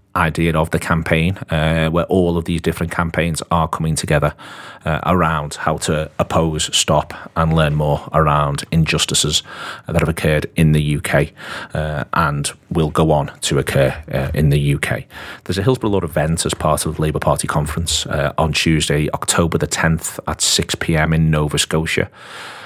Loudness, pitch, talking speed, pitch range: -17 LUFS, 80 Hz, 175 wpm, 75-85 Hz